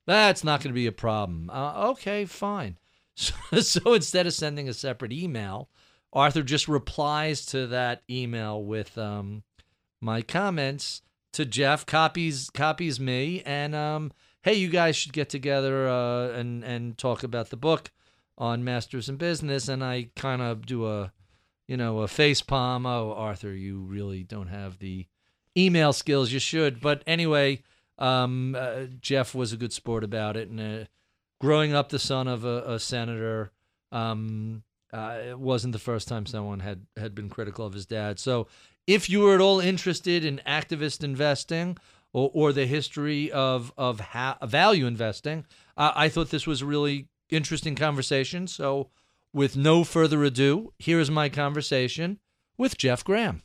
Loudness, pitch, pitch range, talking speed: -26 LUFS, 135 Hz, 115-150 Hz, 165 wpm